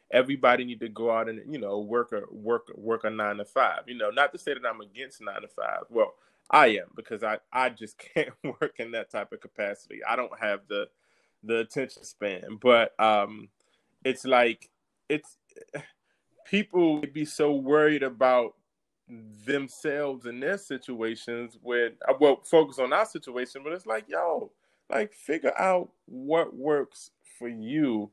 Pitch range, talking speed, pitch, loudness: 115-155 Hz, 170 wpm, 130 Hz, -27 LUFS